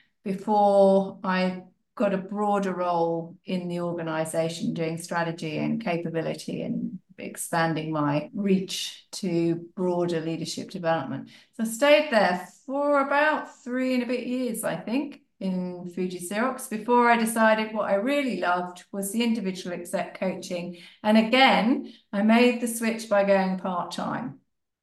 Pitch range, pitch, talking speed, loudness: 175-230 Hz, 195 Hz, 145 wpm, -25 LUFS